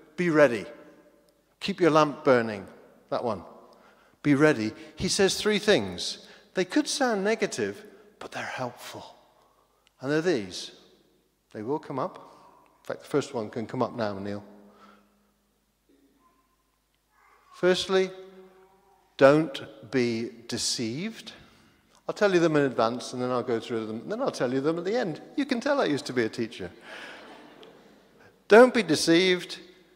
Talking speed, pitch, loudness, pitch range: 150 wpm, 155 Hz, -26 LUFS, 120-195 Hz